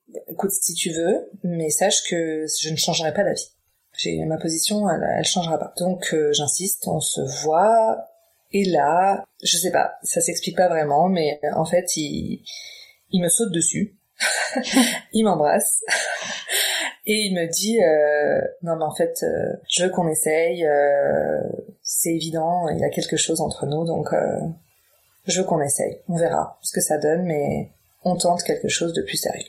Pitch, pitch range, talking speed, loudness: 175 Hz, 160-200 Hz, 180 wpm, -21 LUFS